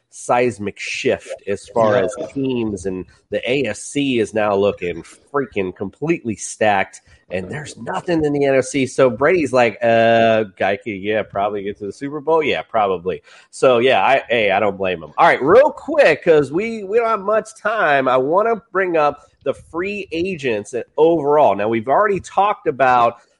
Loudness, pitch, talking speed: -18 LUFS, 140 Hz, 175 wpm